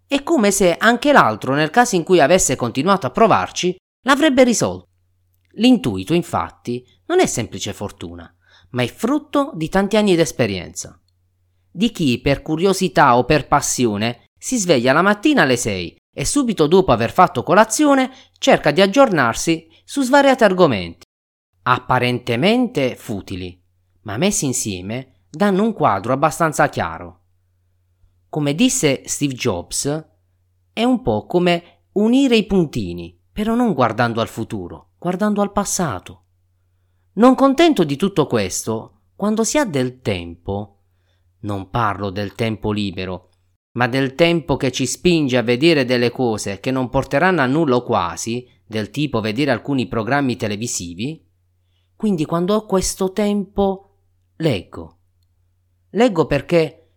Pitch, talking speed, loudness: 125 Hz, 135 wpm, -17 LUFS